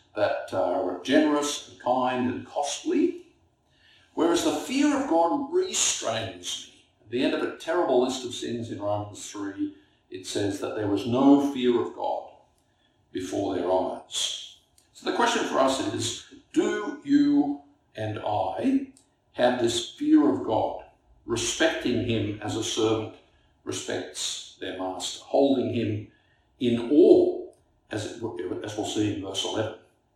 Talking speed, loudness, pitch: 145 wpm, -26 LUFS, 145 Hz